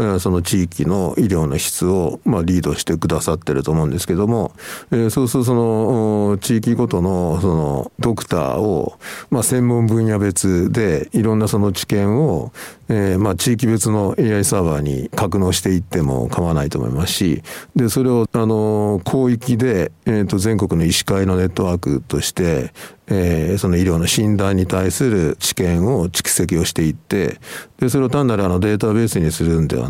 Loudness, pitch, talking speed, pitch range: -18 LUFS, 100 Hz, 340 characters per minute, 90-115 Hz